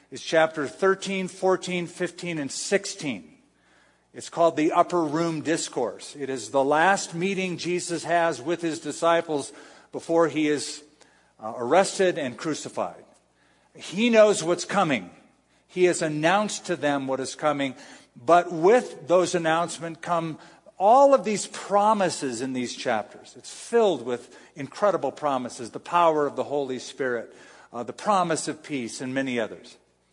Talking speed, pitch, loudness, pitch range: 145 wpm, 165 Hz, -24 LUFS, 145-180 Hz